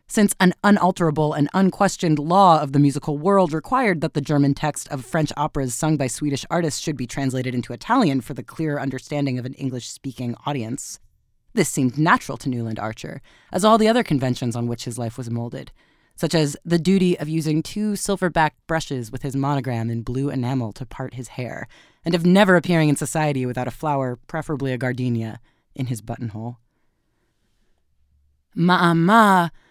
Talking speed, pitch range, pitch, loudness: 180 wpm, 125-165 Hz, 145 Hz, -21 LUFS